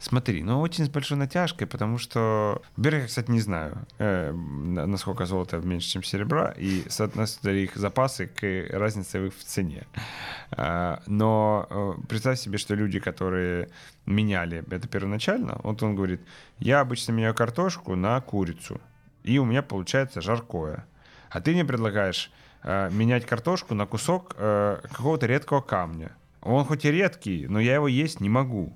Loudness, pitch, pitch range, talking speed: -27 LUFS, 110 Hz, 95-130 Hz, 155 wpm